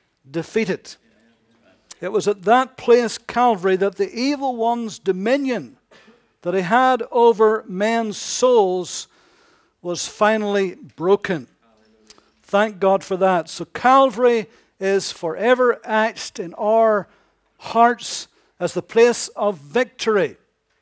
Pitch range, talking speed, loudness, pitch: 190-240 Hz, 110 wpm, -19 LUFS, 215 Hz